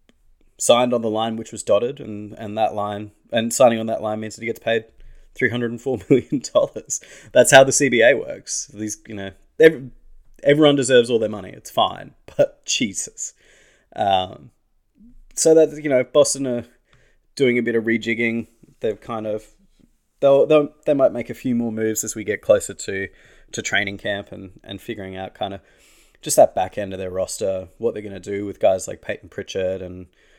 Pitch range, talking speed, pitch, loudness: 105-130 Hz, 200 wpm, 115 Hz, -20 LUFS